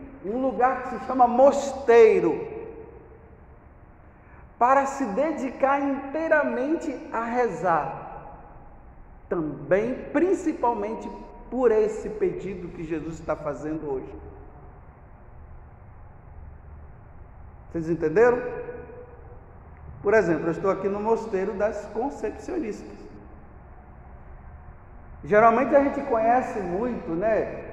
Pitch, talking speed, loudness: 220 Hz, 85 wpm, -24 LUFS